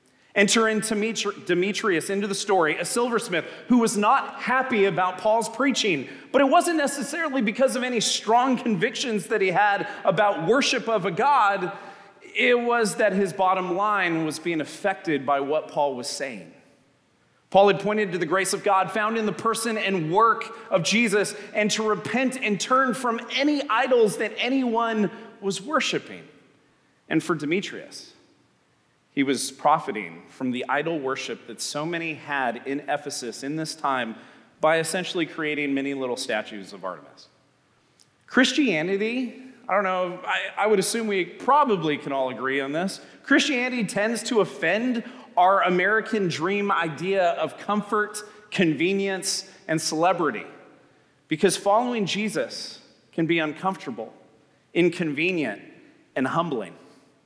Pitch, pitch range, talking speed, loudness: 200 Hz, 170-225 Hz, 145 wpm, -24 LUFS